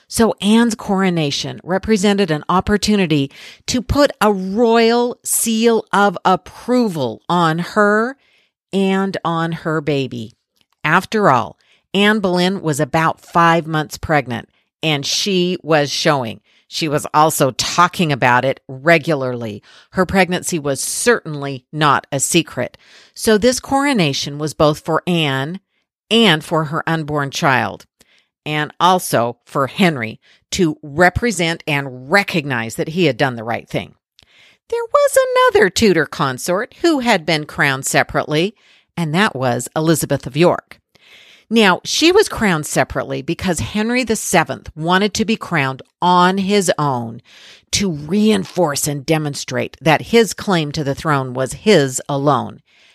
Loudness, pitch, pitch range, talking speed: -16 LUFS, 165 Hz, 145-200 Hz, 135 wpm